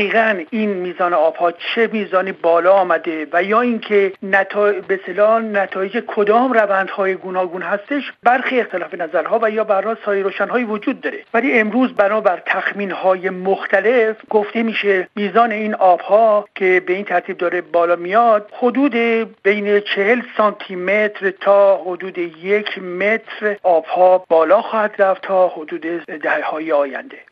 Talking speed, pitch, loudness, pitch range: 140 wpm, 200 Hz, -17 LUFS, 185-220 Hz